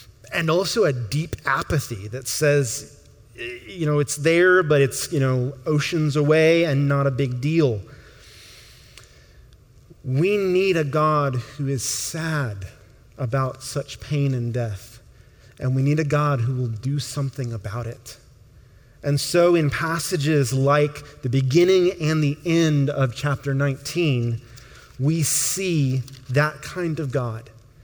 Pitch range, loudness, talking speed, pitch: 125-155 Hz, -22 LUFS, 140 wpm, 140 Hz